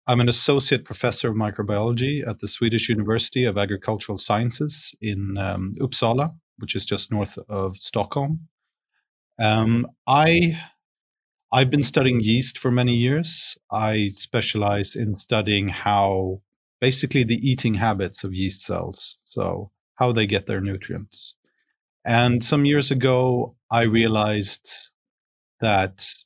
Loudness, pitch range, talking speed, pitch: -21 LUFS, 100-125 Hz, 130 wpm, 115 Hz